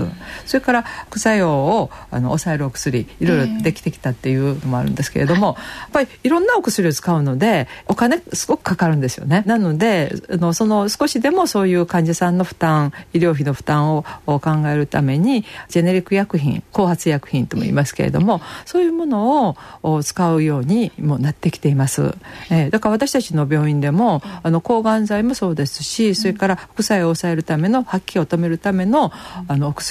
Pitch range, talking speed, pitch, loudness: 150-215 Hz, 385 characters per minute, 175 Hz, -18 LUFS